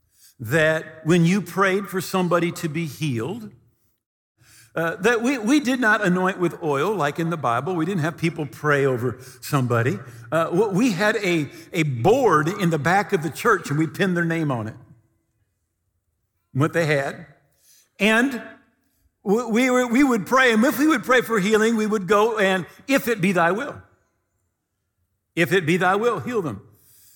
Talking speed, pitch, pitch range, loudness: 175 wpm, 170 Hz, 135-205 Hz, -21 LUFS